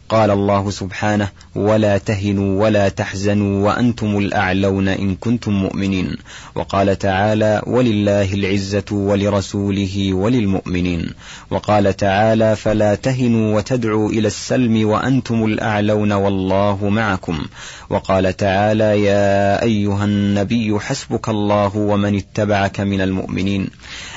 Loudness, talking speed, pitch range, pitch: -17 LUFS, 100 wpm, 100-105 Hz, 100 Hz